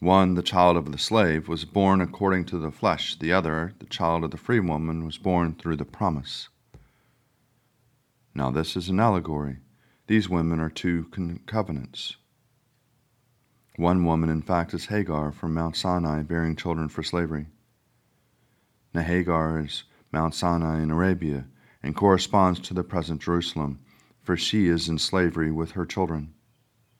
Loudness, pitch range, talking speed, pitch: -26 LUFS, 80-100 Hz, 155 wpm, 85 Hz